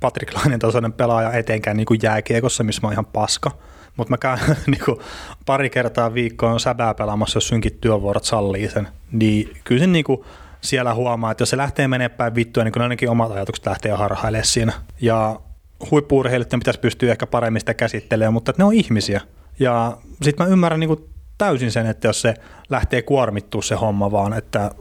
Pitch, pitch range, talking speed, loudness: 115 Hz, 110-125 Hz, 190 wpm, -19 LUFS